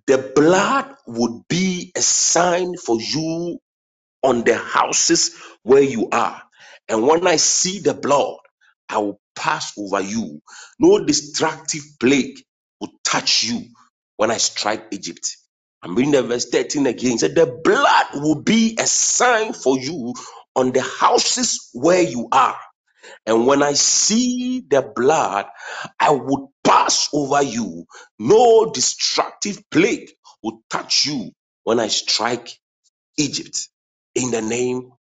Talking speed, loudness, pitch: 140 wpm, -18 LUFS, 170 Hz